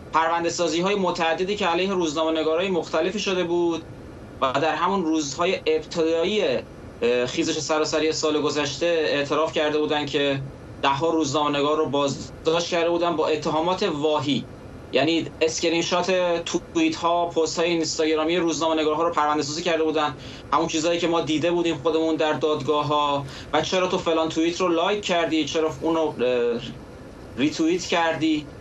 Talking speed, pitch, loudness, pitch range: 135 wpm, 160 Hz, -23 LUFS, 150-170 Hz